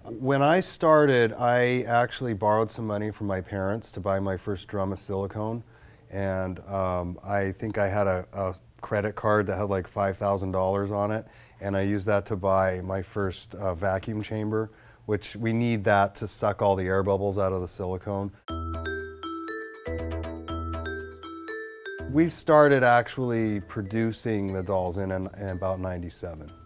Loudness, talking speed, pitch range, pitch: -27 LUFS, 160 wpm, 95-110 Hz, 100 Hz